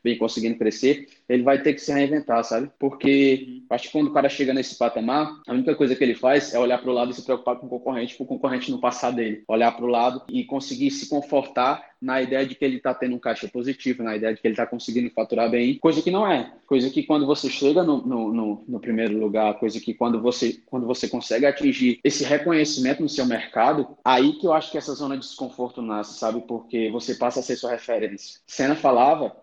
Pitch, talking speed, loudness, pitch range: 125 Hz, 240 wpm, -23 LUFS, 120-140 Hz